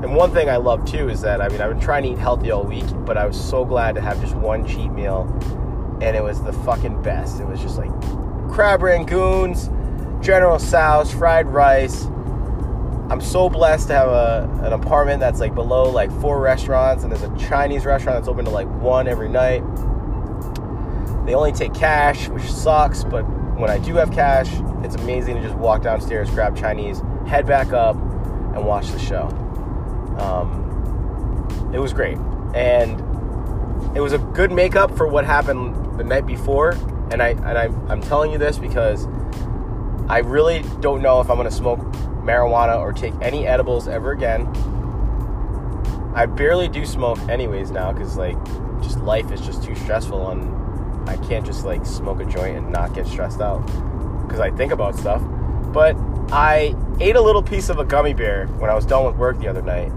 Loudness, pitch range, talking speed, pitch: -20 LUFS, 100-130 Hz, 190 wpm, 115 Hz